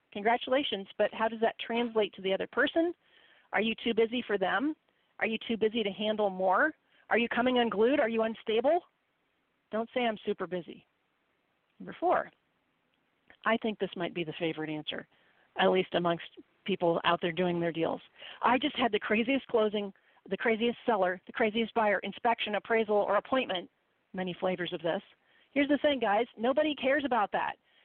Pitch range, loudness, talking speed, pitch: 190-235 Hz, -30 LUFS, 175 wpm, 220 Hz